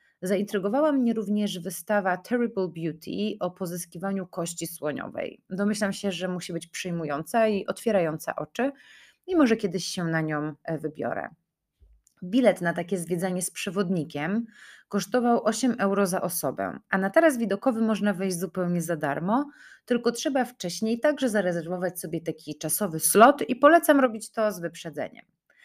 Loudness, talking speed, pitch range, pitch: -26 LUFS, 145 wpm, 170-225 Hz, 195 Hz